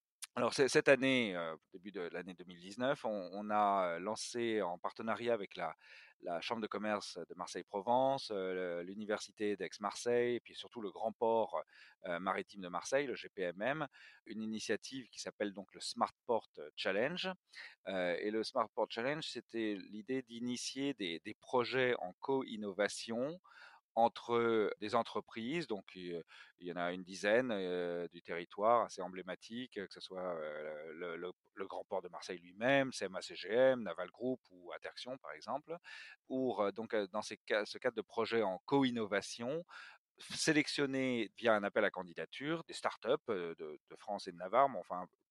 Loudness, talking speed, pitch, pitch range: -38 LUFS, 160 wpm, 115 Hz, 100-135 Hz